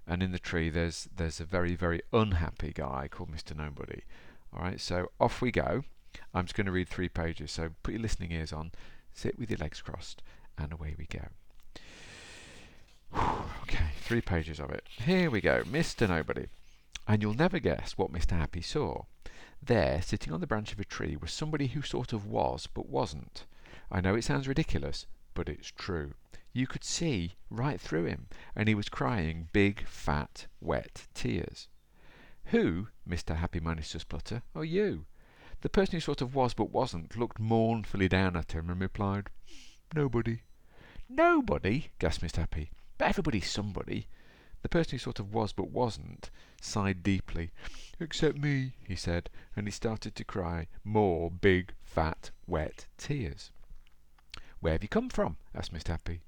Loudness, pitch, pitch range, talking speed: -33 LUFS, 95 Hz, 85-115 Hz, 170 wpm